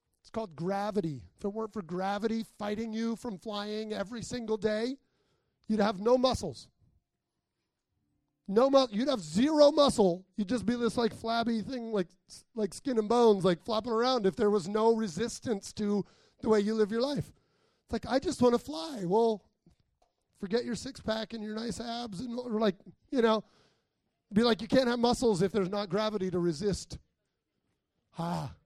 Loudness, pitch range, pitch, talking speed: -30 LUFS, 205-235 Hz, 220 Hz, 180 wpm